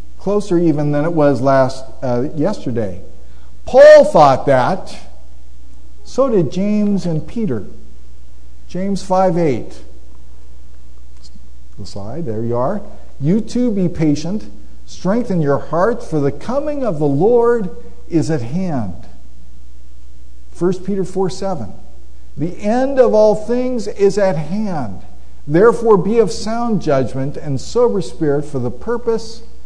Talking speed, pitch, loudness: 125 wpm, 155 Hz, -16 LUFS